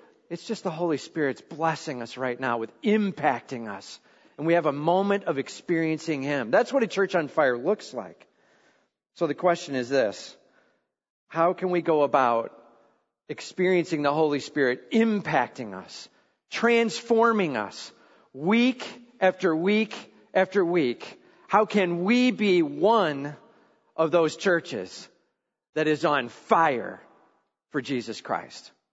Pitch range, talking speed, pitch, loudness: 150-205 Hz, 135 wpm, 170 Hz, -25 LUFS